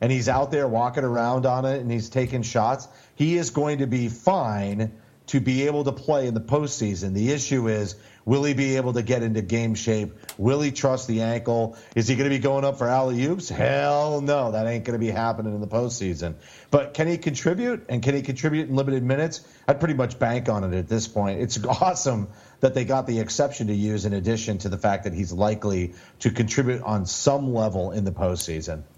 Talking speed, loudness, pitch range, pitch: 225 wpm, -24 LUFS, 110-140 Hz, 120 Hz